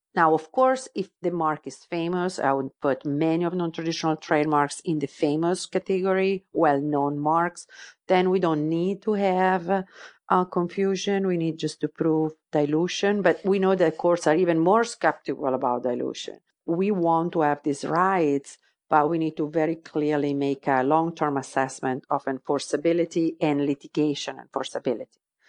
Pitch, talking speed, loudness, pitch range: 165 Hz, 160 wpm, -25 LUFS, 150-185 Hz